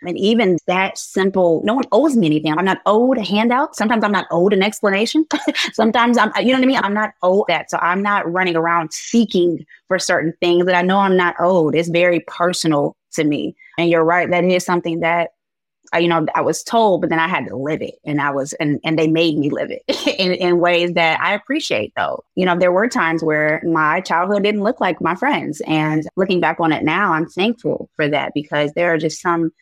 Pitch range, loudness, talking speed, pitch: 165-205 Hz, -17 LUFS, 235 wpm, 175 Hz